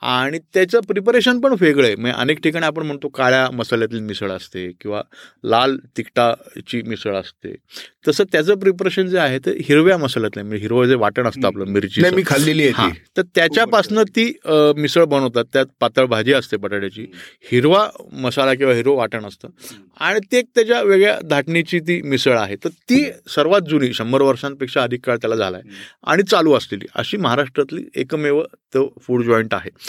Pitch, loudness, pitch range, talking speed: 135 Hz, -17 LUFS, 115-175 Hz, 165 wpm